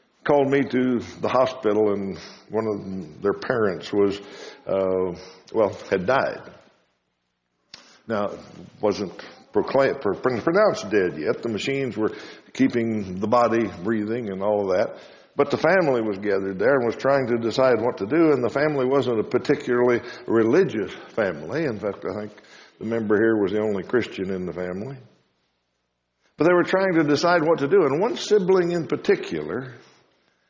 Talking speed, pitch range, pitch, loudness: 165 wpm, 95-140 Hz, 115 Hz, -23 LUFS